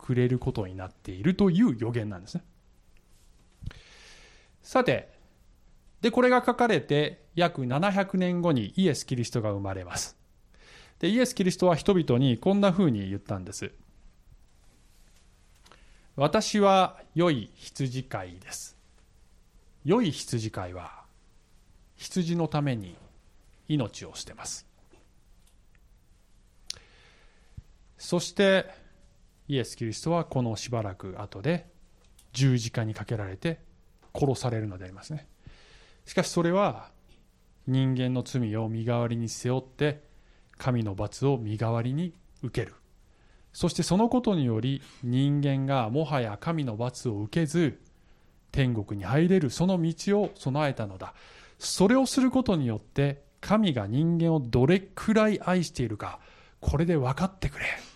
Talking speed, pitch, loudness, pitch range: 250 characters per minute, 135 Hz, -27 LUFS, 110-175 Hz